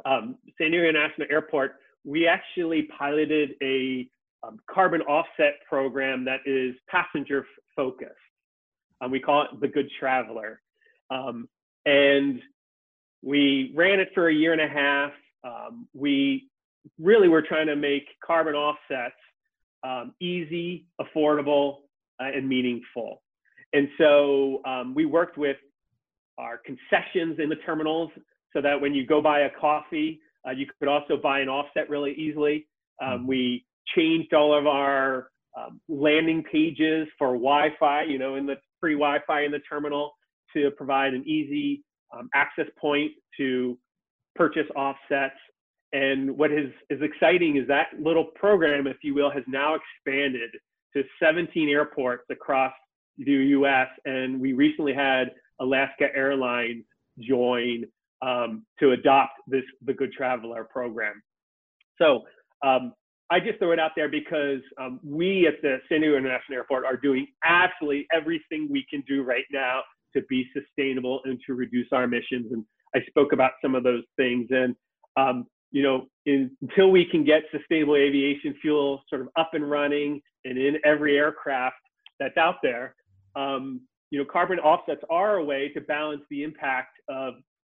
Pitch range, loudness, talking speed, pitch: 135-155 Hz, -25 LUFS, 155 wpm, 145 Hz